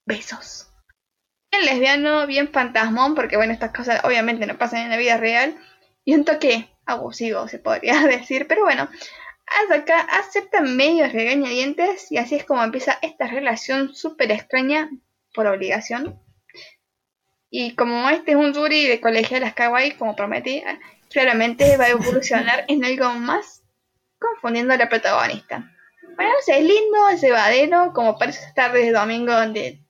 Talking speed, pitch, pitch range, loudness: 155 wpm, 260 Hz, 235-300 Hz, -19 LUFS